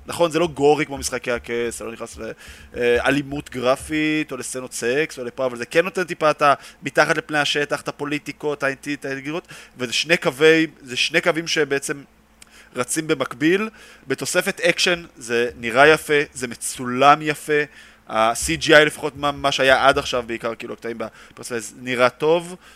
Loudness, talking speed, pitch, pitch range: -20 LUFS, 160 wpm, 145 Hz, 125-155 Hz